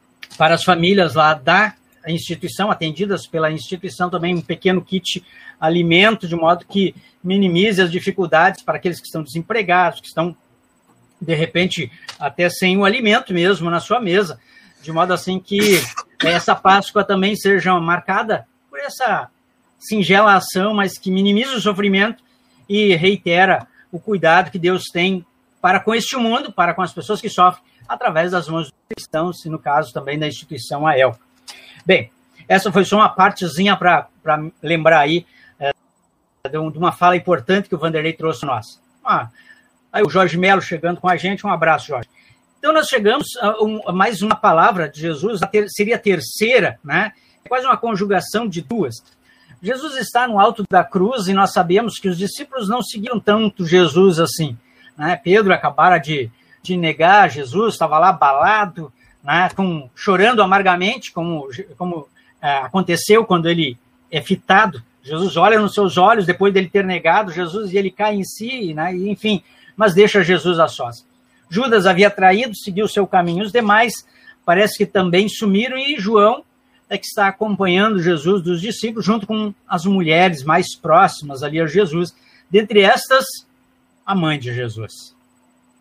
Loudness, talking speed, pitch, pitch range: -16 LUFS, 170 wpm, 185 Hz, 165-205 Hz